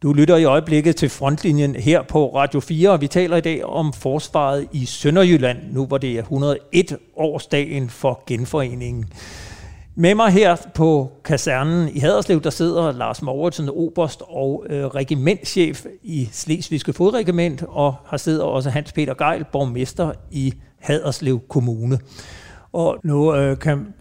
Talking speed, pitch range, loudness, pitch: 150 wpm, 135-165 Hz, -19 LUFS, 145 Hz